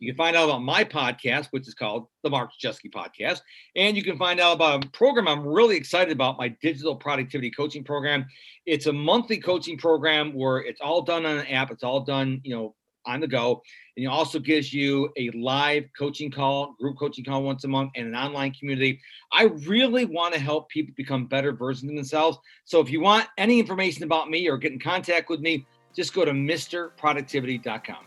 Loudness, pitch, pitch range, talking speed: -24 LUFS, 145 Hz, 135-165 Hz, 210 wpm